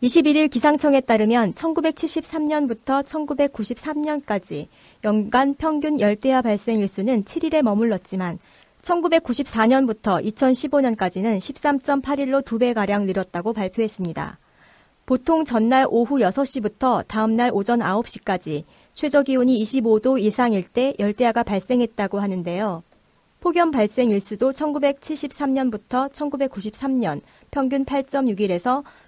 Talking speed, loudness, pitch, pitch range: 230 characters per minute, -21 LUFS, 250 Hz, 215-285 Hz